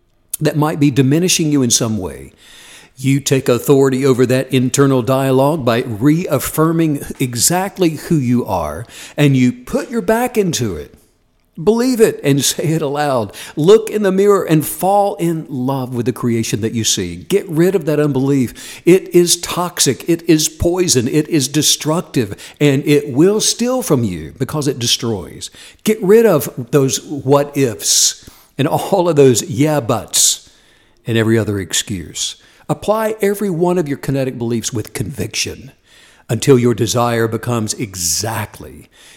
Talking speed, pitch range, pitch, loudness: 155 wpm, 120-170 Hz, 140 Hz, -15 LUFS